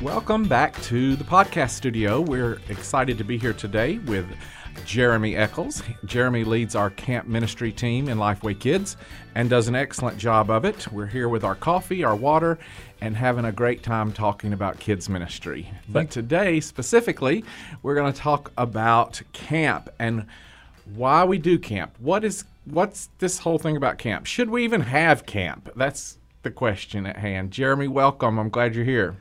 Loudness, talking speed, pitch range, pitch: -23 LUFS, 175 wpm, 105-145 Hz, 120 Hz